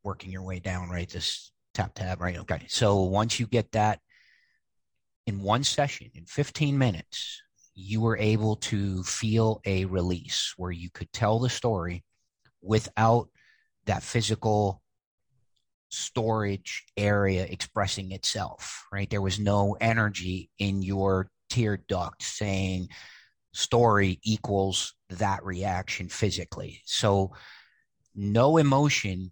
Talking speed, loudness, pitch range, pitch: 120 wpm, -28 LUFS, 95-115 Hz, 100 Hz